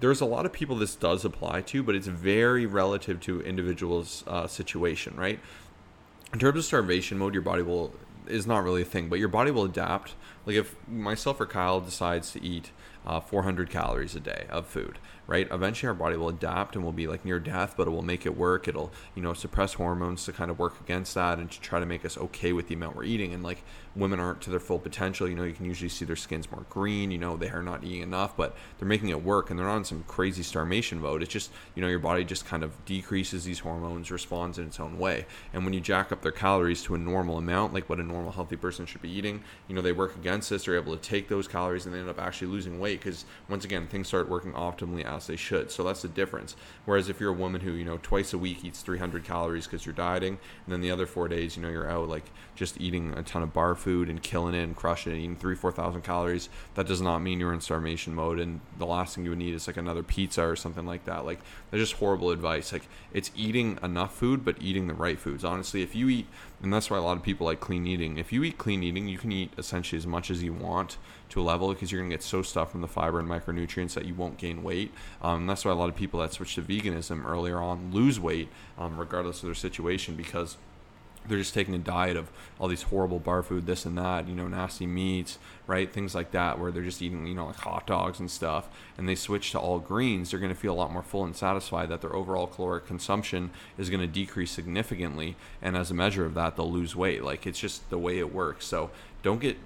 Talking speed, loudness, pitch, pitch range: 260 wpm, -31 LUFS, 90 Hz, 85-95 Hz